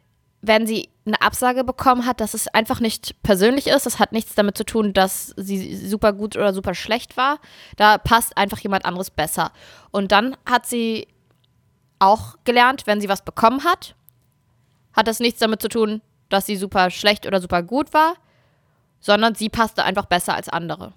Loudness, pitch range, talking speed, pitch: -19 LUFS, 195-230 Hz, 185 wpm, 215 Hz